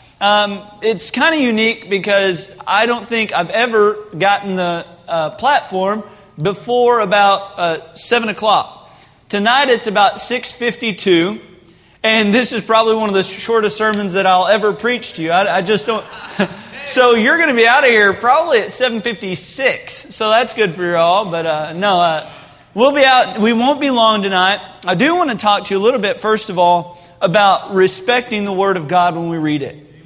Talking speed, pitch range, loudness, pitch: 195 wpm, 185-230 Hz, -14 LUFS, 205 Hz